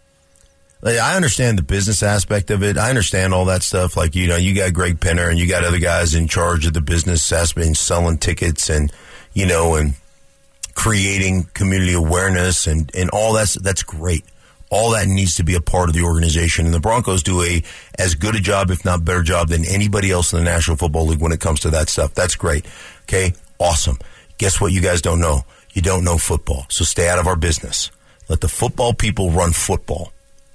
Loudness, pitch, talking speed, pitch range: -17 LUFS, 90 Hz, 215 wpm, 85-95 Hz